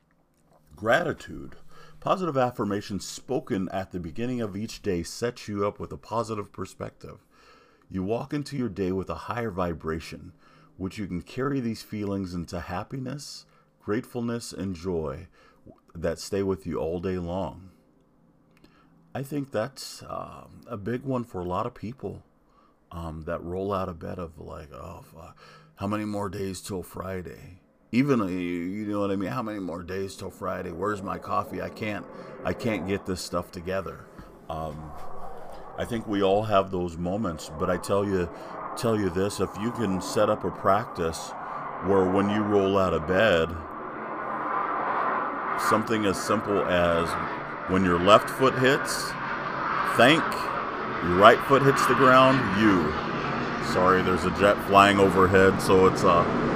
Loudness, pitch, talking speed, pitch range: -26 LUFS, 95 Hz, 160 wpm, 90-110 Hz